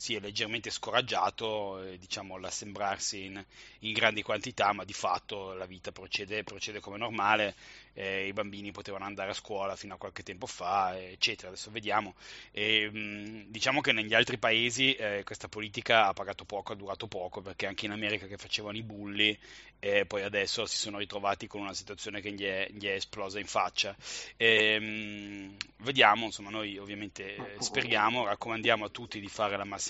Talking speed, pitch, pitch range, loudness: 180 wpm, 105 Hz, 100-110 Hz, -31 LUFS